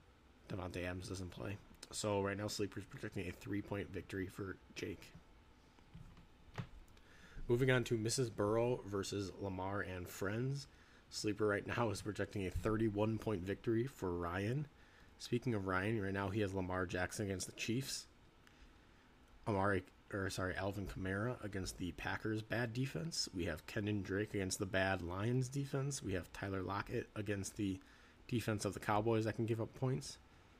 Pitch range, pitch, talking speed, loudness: 95-115 Hz, 100 Hz, 155 wpm, -41 LUFS